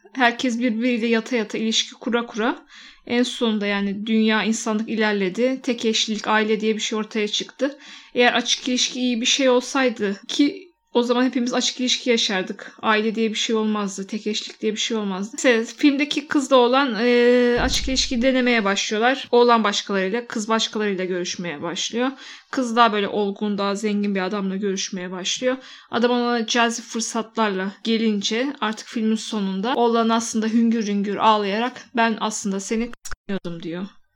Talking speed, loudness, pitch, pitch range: 155 wpm, -21 LUFS, 230 Hz, 210-250 Hz